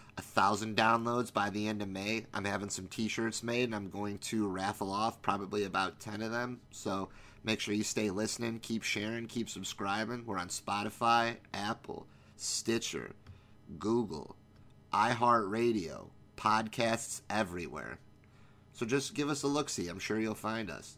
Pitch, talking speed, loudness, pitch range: 110 Hz, 160 wpm, -34 LUFS, 105-115 Hz